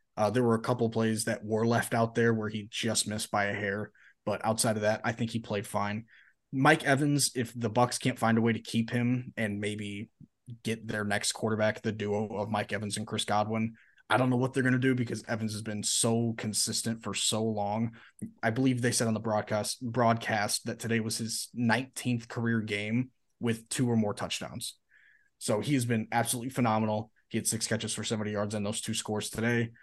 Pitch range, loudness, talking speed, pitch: 105-120 Hz, -30 LUFS, 220 wpm, 115 Hz